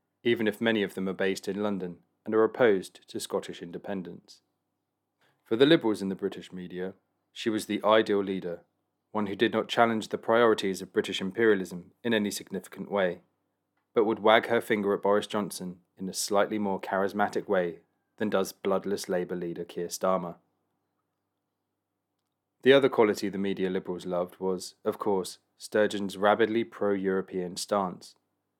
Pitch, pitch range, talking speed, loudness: 100 Hz, 95-105 Hz, 160 wpm, -28 LUFS